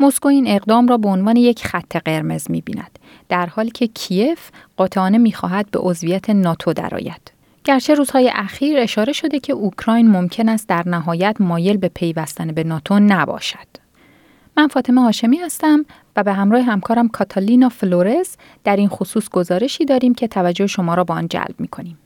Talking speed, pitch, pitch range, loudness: 165 wpm, 205 Hz, 180-245 Hz, -17 LUFS